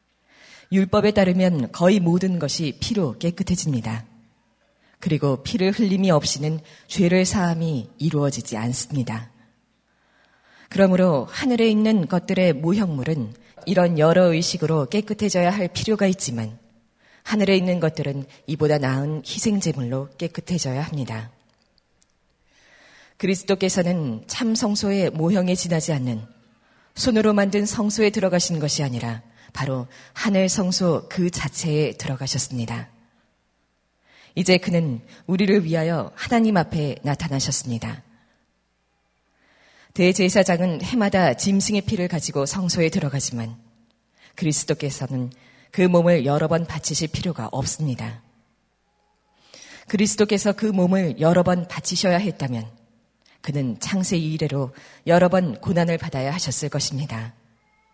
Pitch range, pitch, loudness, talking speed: 130-185 Hz, 160 Hz, -21 LUFS, 280 characters per minute